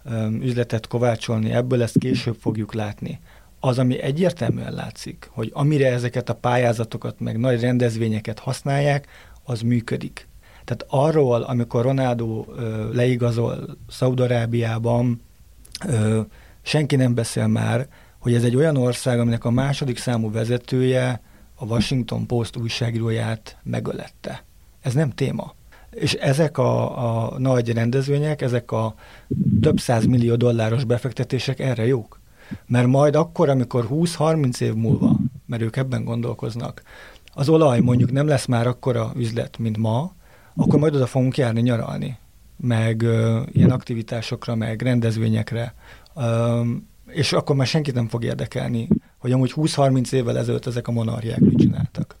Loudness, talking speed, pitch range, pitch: -21 LUFS, 135 wpm, 115-130 Hz, 120 Hz